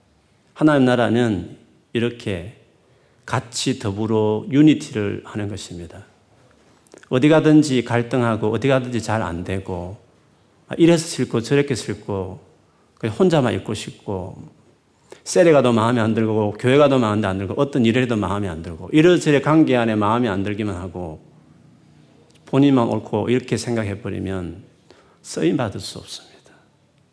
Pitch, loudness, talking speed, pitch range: 115 Hz, -19 LUFS, 290 characters per minute, 100-130 Hz